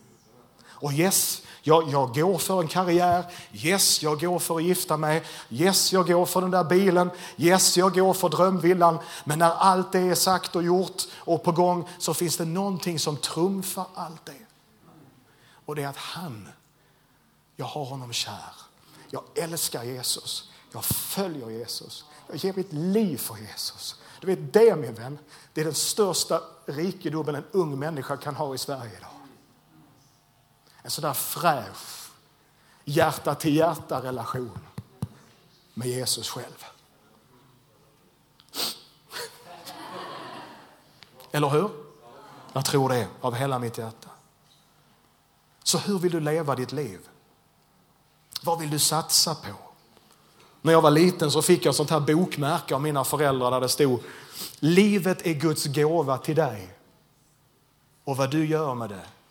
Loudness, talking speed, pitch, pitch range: -24 LUFS, 145 wpm, 155 Hz, 140-180 Hz